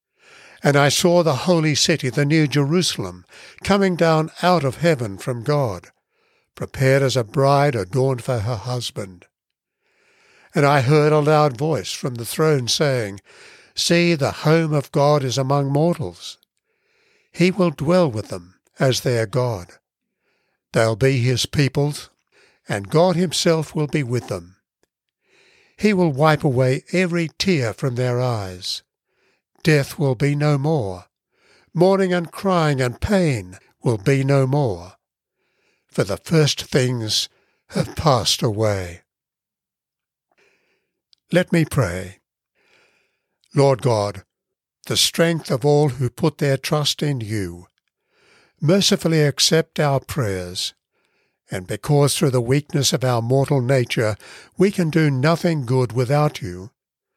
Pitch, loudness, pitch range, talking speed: 145 Hz, -19 LUFS, 125-165 Hz, 130 wpm